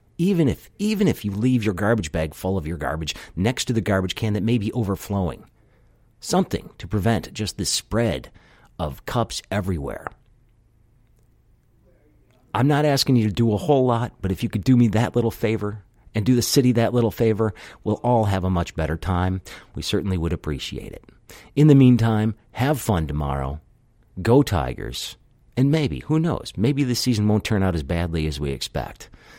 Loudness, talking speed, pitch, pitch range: -22 LUFS, 185 wpm, 110 Hz, 95-120 Hz